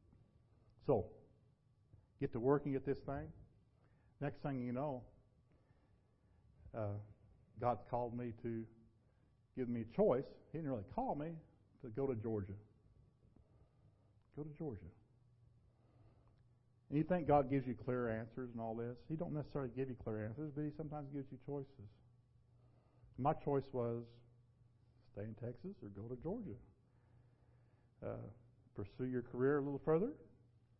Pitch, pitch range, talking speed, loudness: 120 Hz, 115-135 Hz, 140 wpm, -42 LUFS